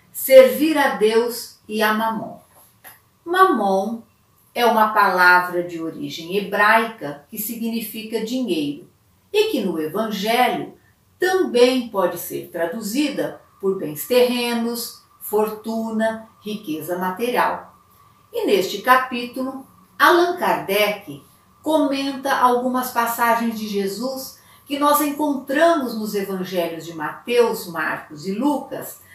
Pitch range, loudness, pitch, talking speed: 200-265 Hz, -20 LUFS, 230 Hz, 105 wpm